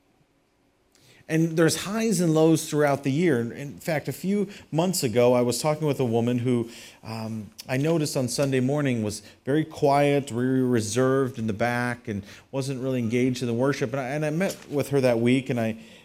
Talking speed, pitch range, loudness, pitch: 200 wpm, 120-150 Hz, -25 LUFS, 135 Hz